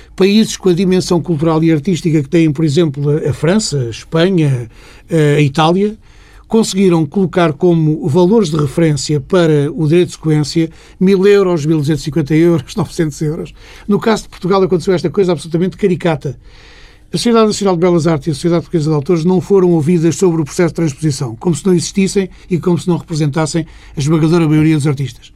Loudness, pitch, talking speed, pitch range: -13 LUFS, 165 Hz, 185 wpm, 155-185 Hz